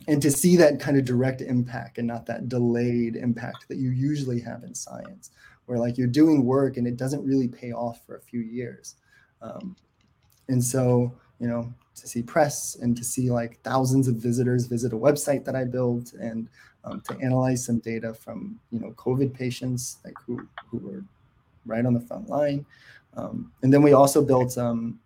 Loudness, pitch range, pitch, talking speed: -24 LUFS, 120-135 Hz, 125 Hz, 200 wpm